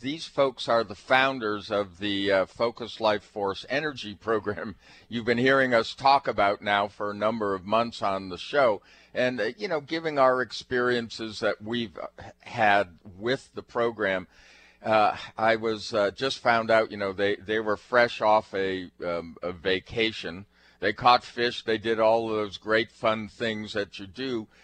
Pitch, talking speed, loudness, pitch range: 110 Hz, 180 wpm, -26 LUFS, 100-120 Hz